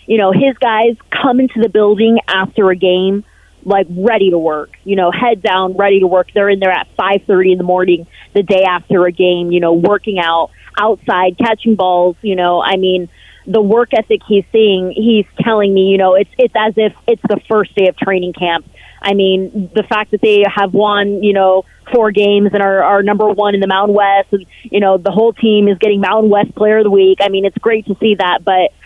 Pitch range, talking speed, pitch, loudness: 185-215 Hz, 230 wpm, 200 Hz, -12 LUFS